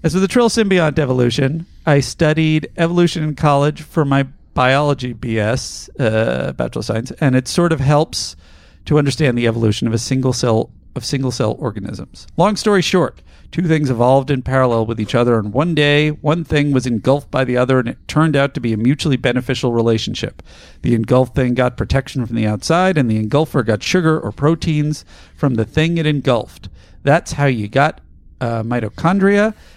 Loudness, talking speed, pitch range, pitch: -16 LUFS, 185 wpm, 115-150 Hz, 130 Hz